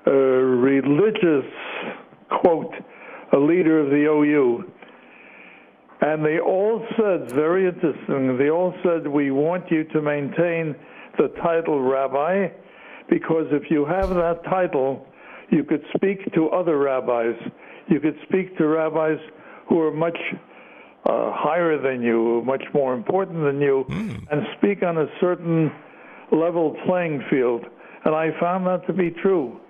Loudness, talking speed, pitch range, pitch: -21 LUFS, 140 wpm, 145-180 Hz, 160 Hz